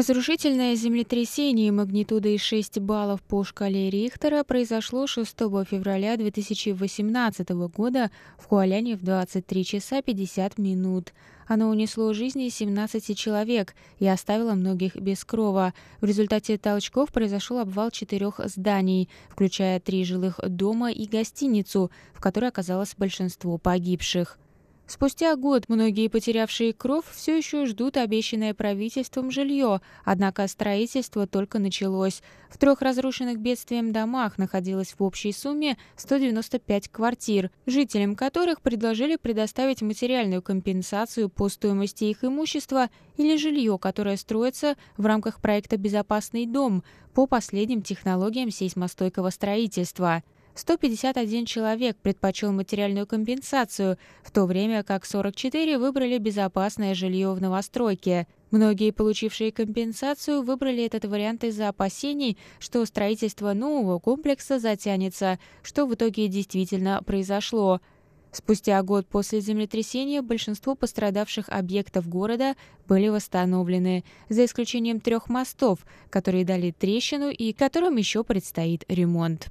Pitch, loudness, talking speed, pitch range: 215 Hz, -26 LUFS, 115 wpm, 195-240 Hz